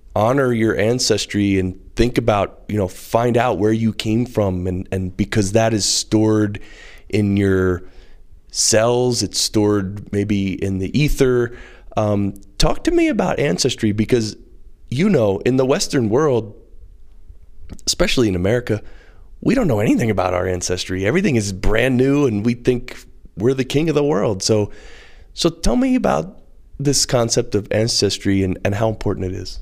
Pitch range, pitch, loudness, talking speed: 95-120 Hz, 105 Hz, -18 LUFS, 160 wpm